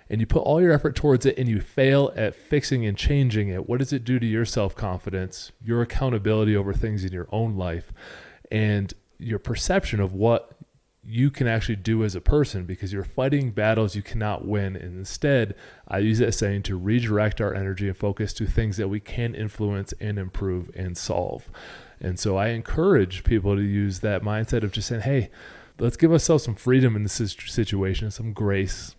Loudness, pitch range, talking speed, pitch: -24 LUFS, 100-120 Hz, 195 wpm, 110 Hz